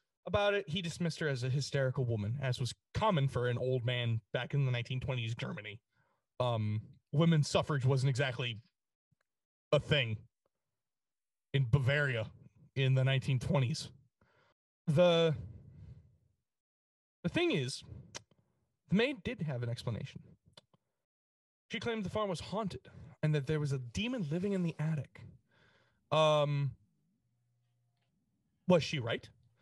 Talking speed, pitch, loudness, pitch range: 130 wpm, 135 Hz, -34 LUFS, 120-155 Hz